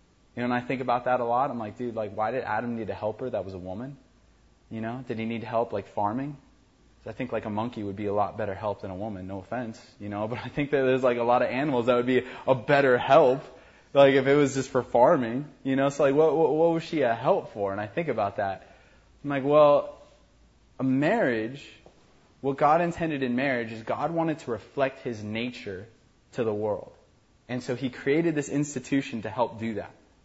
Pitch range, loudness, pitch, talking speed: 110-135 Hz, -26 LUFS, 125 Hz, 240 wpm